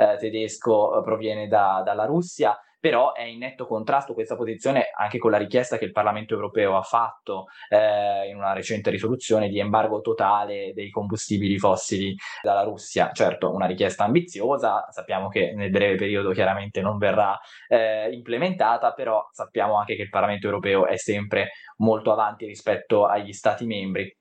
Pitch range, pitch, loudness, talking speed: 100-110 Hz, 105 Hz, -24 LUFS, 160 wpm